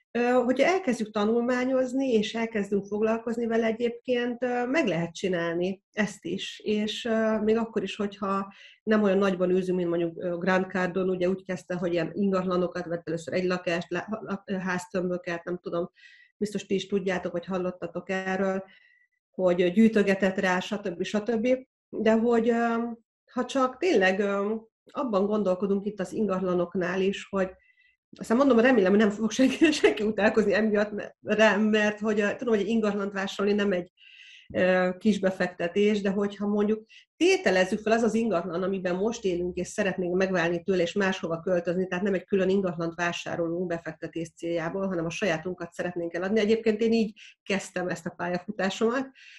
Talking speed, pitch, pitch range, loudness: 150 wpm, 200 Hz, 180-225 Hz, -27 LUFS